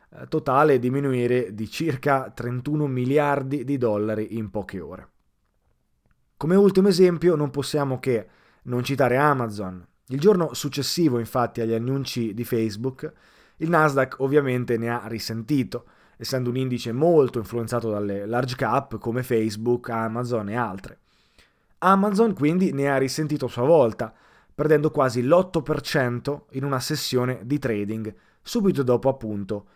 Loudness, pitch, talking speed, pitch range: -23 LUFS, 130 Hz, 135 wpm, 115-145 Hz